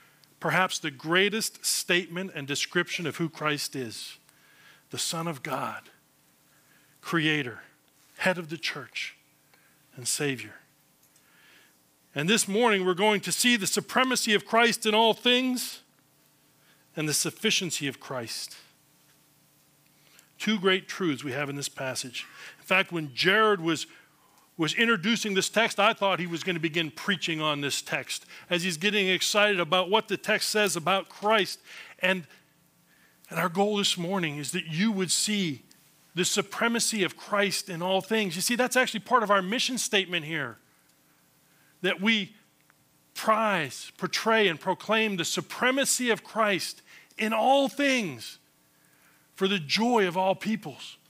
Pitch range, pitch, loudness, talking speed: 150-215 Hz, 185 Hz, -26 LUFS, 150 wpm